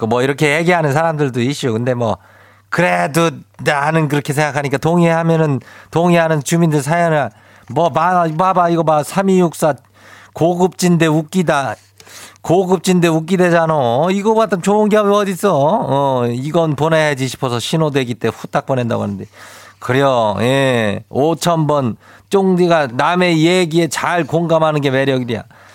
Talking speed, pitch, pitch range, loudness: 290 characters per minute, 155 Hz, 125-170 Hz, -15 LUFS